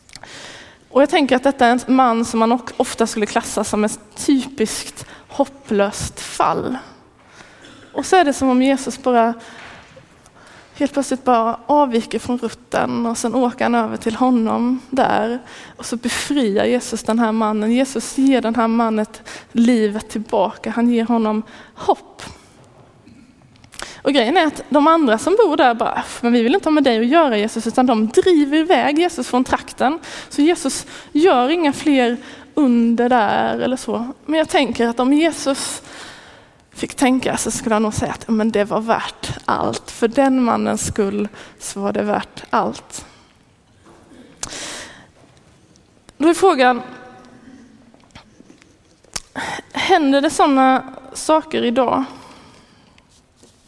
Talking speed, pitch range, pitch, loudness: 145 wpm, 230-280 Hz, 250 Hz, -17 LUFS